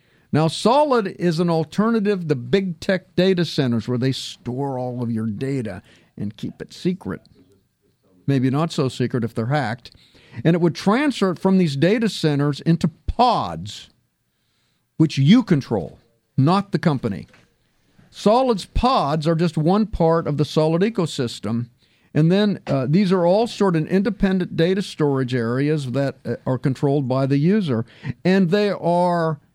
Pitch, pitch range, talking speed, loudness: 155 Hz, 130-185 Hz, 155 wpm, -20 LUFS